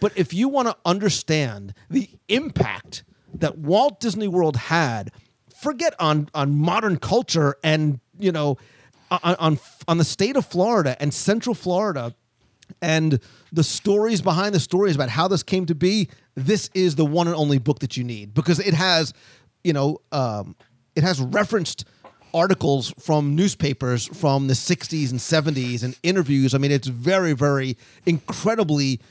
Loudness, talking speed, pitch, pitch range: -22 LUFS, 160 wpm, 155 Hz, 135-185 Hz